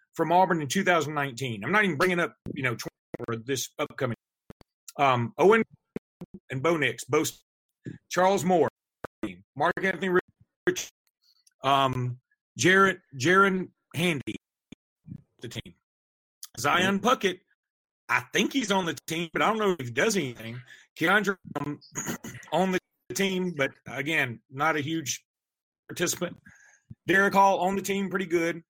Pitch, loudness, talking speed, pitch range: 165 Hz, -26 LUFS, 135 wpm, 135-190 Hz